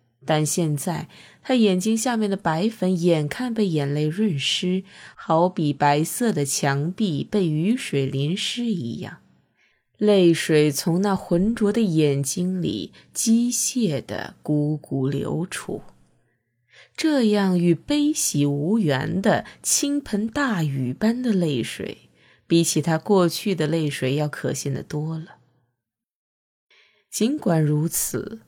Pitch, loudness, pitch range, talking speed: 170 Hz, -22 LUFS, 150-215 Hz, 175 characters per minute